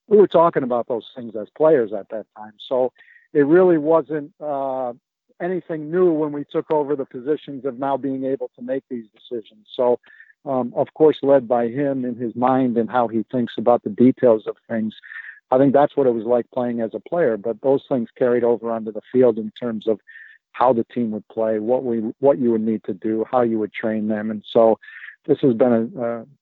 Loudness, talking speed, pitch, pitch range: -20 LUFS, 225 wpm, 125 Hz, 115-140 Hz